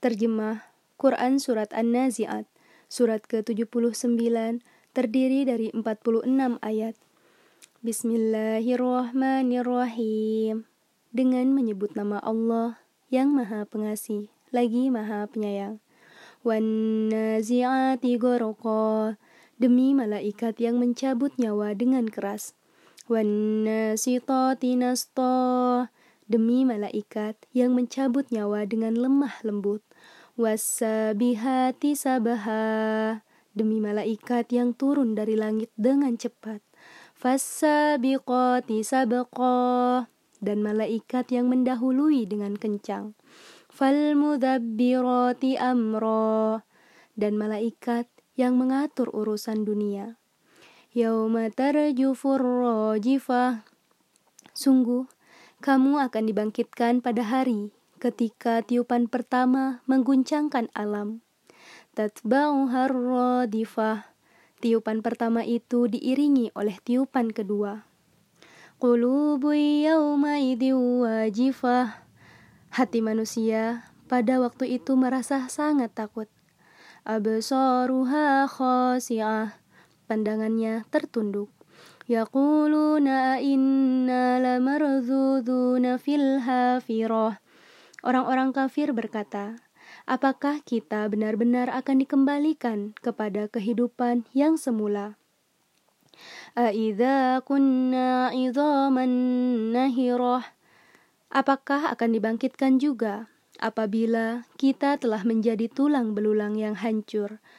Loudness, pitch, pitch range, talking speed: -25 LUFS, 245 Hz, 220-260 Hz, 70 wpm